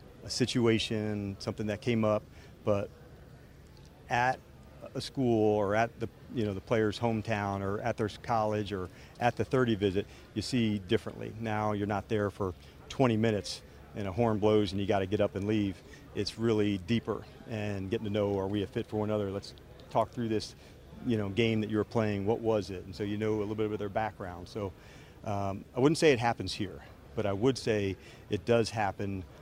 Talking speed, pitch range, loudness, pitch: 210 wpm, 100-115 Hz, -32 LUFS, 105 Hz